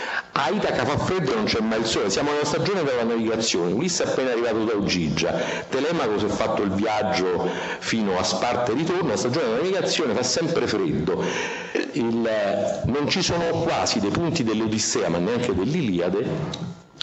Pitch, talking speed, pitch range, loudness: 115 Hz, 175 wpm, 110-165 Hz, -23 LUFS